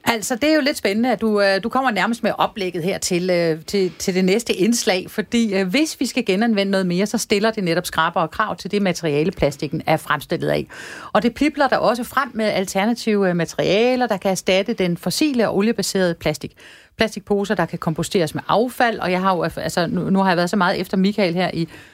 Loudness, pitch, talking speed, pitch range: -19 LUFS, 195 Hz, 210 wpm, 175-225 Hz